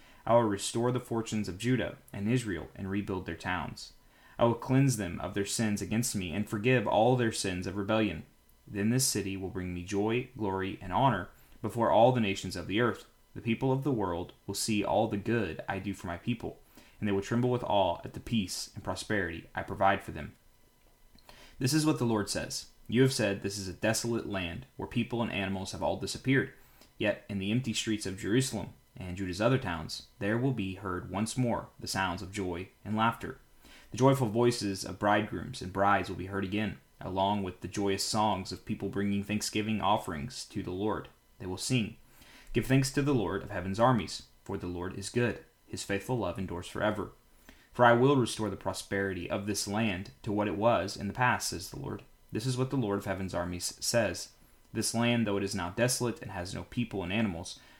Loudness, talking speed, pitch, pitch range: -31 LUFS, 215 wpm, 105 Hz, 95-120 Hz